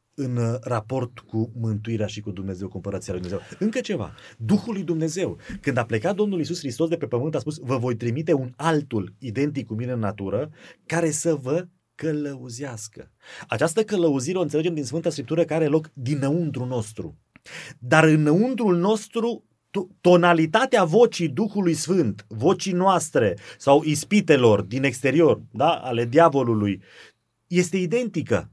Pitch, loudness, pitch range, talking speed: 150 Hz, -23 LUFS, 120-175 Hz, 145 wpm